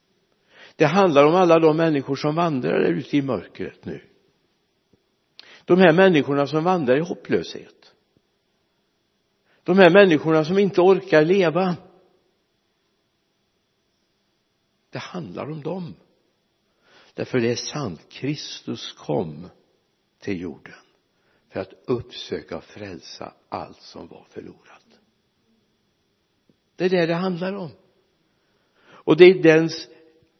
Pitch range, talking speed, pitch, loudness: 155-185 Hz, 110 wpm, 165 Hz, -19 LUFS